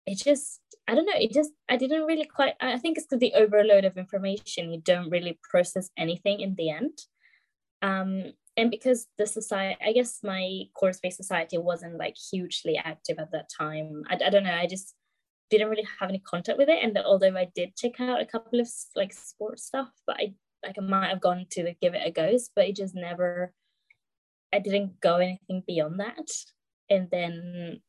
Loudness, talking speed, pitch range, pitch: -27 LUFS, 200 wpm, 180-235 Hz, 195 Hz